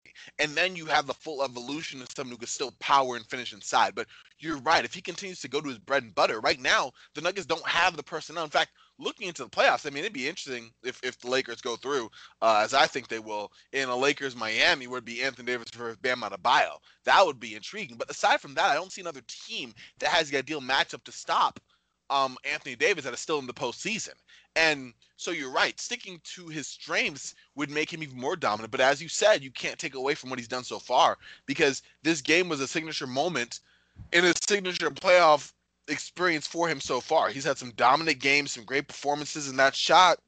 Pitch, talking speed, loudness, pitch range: 140 Hz, 235 wpm, -27 LUFS, 125-160 Hz